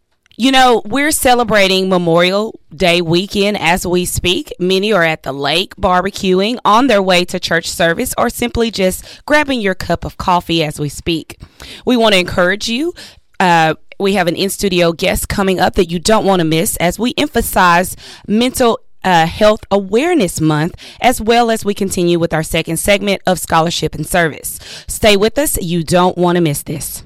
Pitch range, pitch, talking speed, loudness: 170-215 Hz, 185 Hz, 185 wpm, -13 LUFS